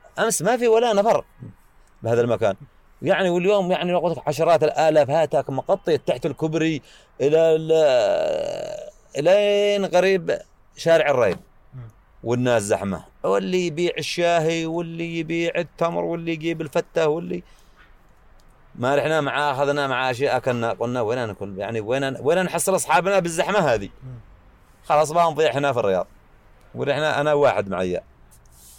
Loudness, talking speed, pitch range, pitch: -21 LUFS, 125 wpm, 125-175 Hz, 155 Hz